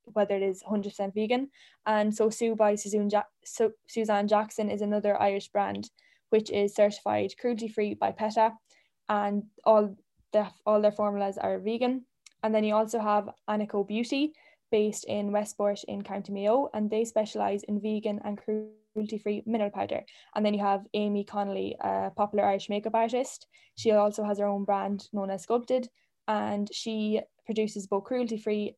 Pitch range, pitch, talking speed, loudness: 205-220 Hz, 210 Hz, 165 wpm, -29 LUFS